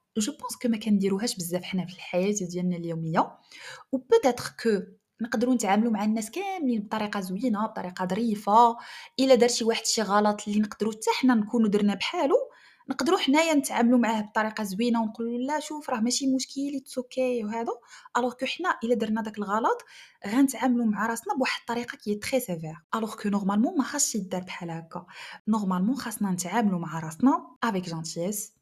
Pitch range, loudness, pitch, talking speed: 205-255 Hz, -27 LUFS, 225 Hz, 170 wpm